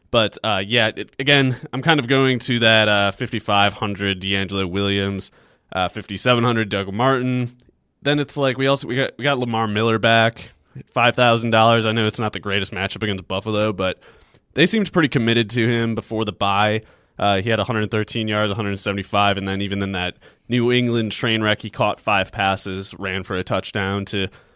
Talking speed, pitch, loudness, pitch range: 190 wpm, 110 Hz, -19 LUFS, 100-120 Hz